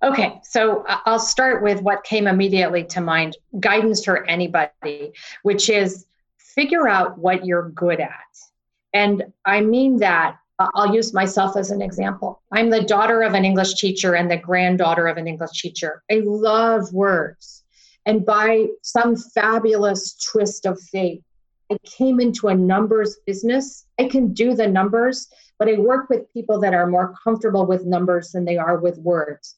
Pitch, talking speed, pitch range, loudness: 200 Hz, 165 wpm, 180-225 Hz, -19 LUFS